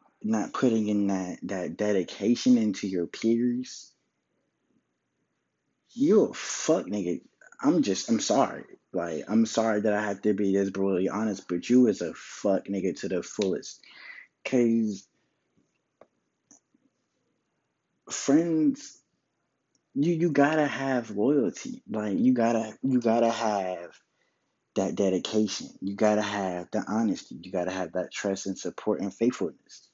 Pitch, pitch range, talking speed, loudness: 110 Hz, 100-125 Hz, 130 wpm, -27 LUFS